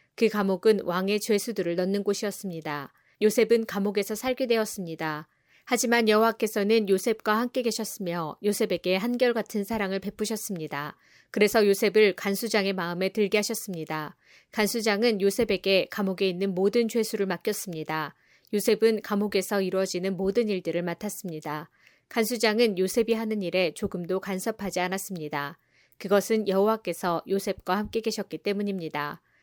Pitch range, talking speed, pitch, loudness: 185-220 Hz, 360 characters per minute, 205 Hz, -27 LUFS